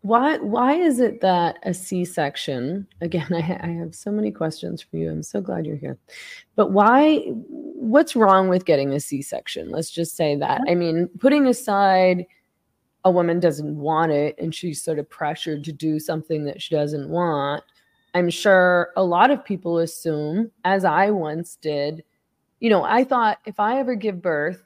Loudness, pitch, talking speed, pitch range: -21 LUFS, 175 Hz, 185 wpm, 160-210 Hz